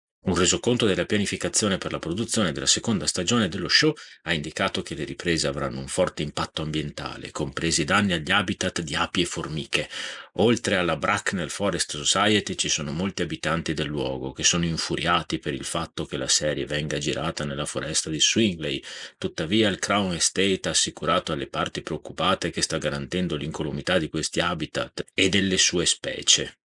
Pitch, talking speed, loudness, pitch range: 90 Hz, 170 wpm, -24 LUFS, 75-95 Hz